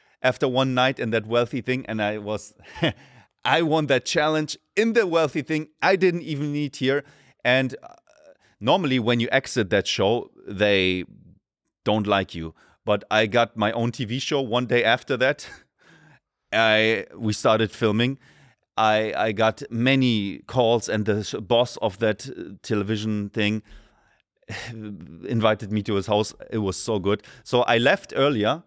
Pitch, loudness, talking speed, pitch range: 115 Hz, -23 LUFS, 155 wpm, 105-130 Hz